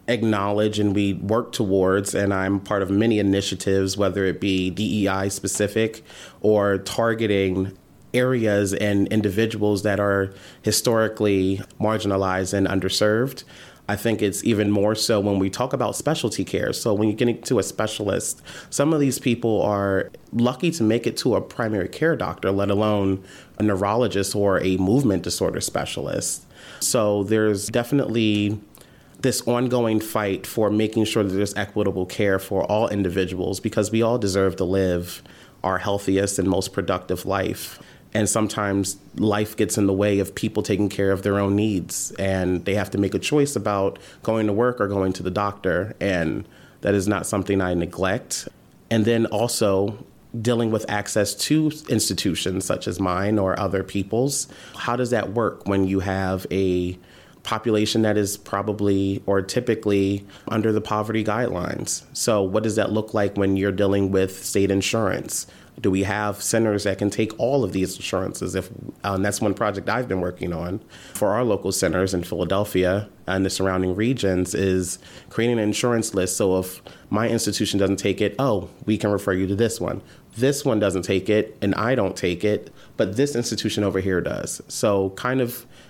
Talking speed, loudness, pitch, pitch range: 175 wpm, -22 LUFS, 100 Hz, 95-110 Hz